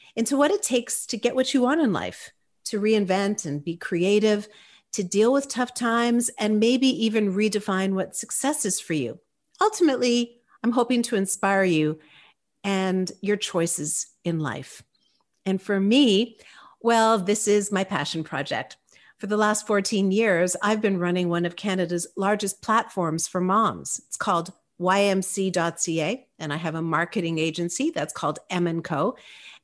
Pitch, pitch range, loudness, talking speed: 205 Hz, 175-230 Hz, -24 LUFS, 160 wpm